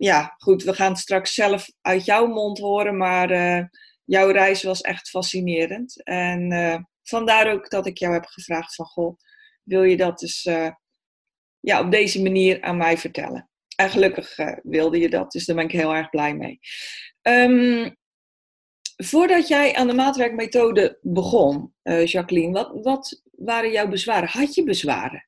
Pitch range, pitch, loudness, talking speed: 175-230 Hz, 190 Hz, -20 LUFS, 170 wpm